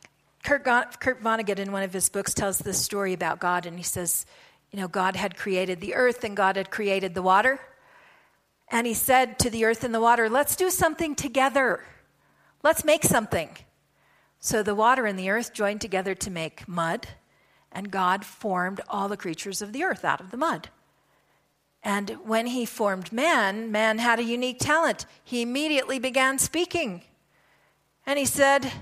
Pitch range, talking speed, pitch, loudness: 195-260 Hz, 180 wpm, 220 Hz, -25 LUFS